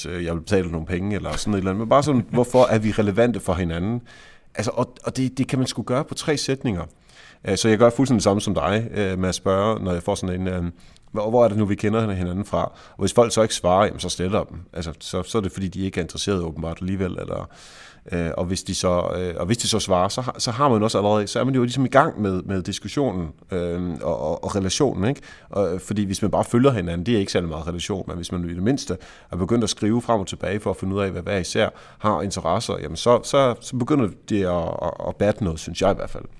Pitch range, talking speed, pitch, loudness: 90-115 Hz, 270 wpm, 100 Hz, -22 LUFS